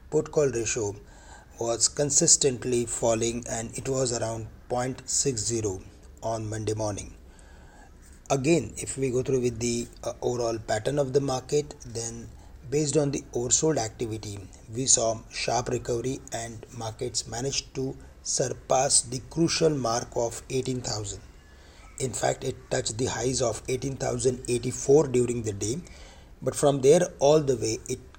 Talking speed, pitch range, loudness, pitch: 135 wpm, 110-130 Hz, -26 LUFS, 120 Hz